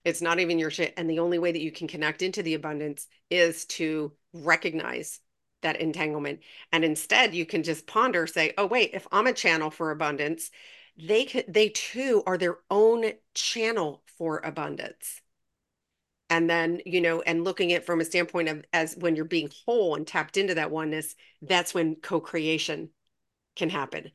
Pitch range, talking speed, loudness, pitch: 155-175 Hz, 180 wpm, -27 LUFS, 165 Hz